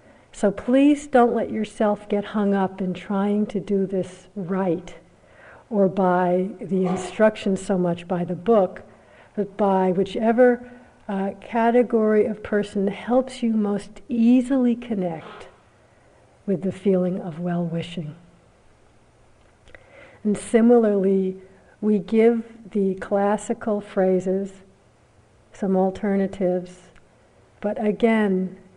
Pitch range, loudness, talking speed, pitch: 185-220 Hz, -22 LUFS, 110 wpm, 200 Hz